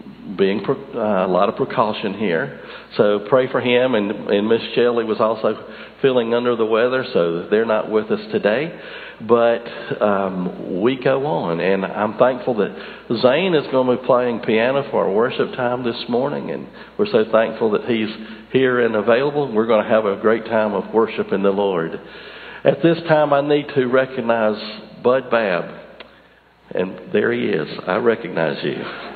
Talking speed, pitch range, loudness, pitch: 175 wpm, 110-130 Hz, -19 LUFS, 115 Hz